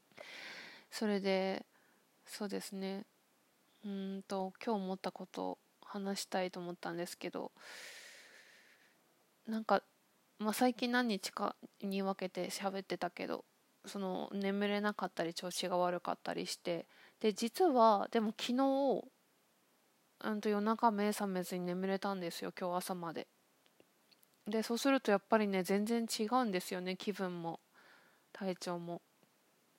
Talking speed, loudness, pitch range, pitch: 255 characters per minute, -37 LUFS, 185-225 Hz, 200 Hz